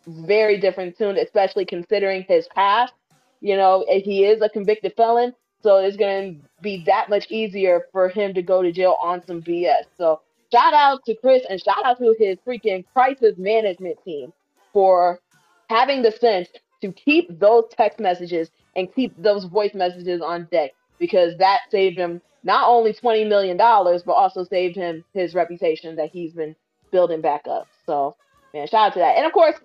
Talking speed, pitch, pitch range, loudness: 180 wpm, 195 Hz, 175-225 Hz, -19 LUFS